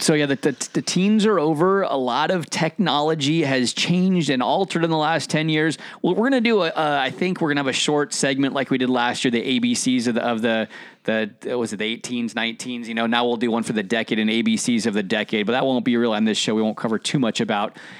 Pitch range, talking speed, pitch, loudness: 120-180 Hz, 275 wpm, 145 Hz, -21 LUFS